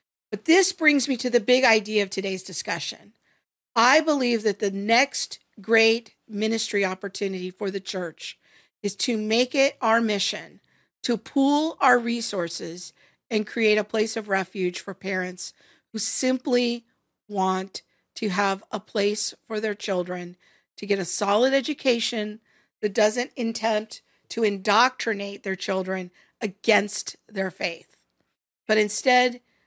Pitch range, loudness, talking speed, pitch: 195-235 Hz, -24 LUFS, 135 wpm, 215 Hz